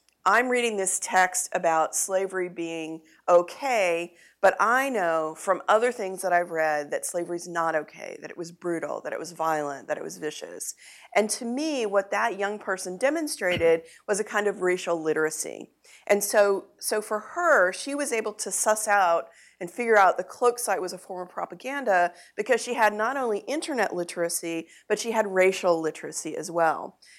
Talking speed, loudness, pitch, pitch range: 185 wpm, -26 LUFS, 190 Hz, 170-220 Hz